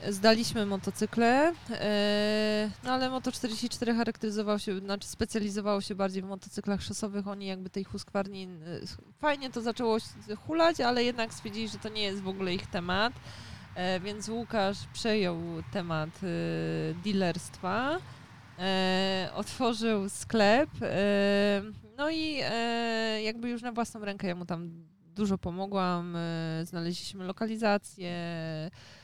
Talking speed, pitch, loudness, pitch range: 110 wpm, 205 Hz, -31 LUFS, 185-225 Hz